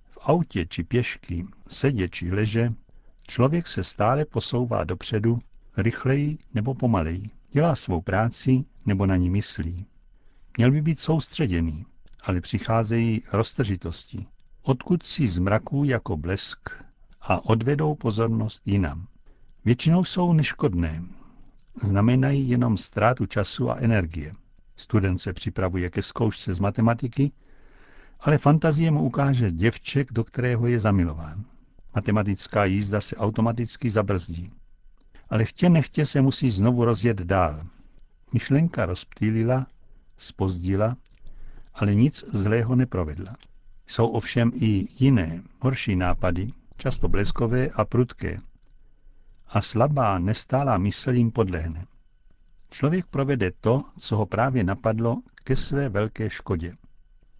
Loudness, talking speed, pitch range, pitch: -24 LUFS, 115 wpm, 95-130 Hz, 115 Hz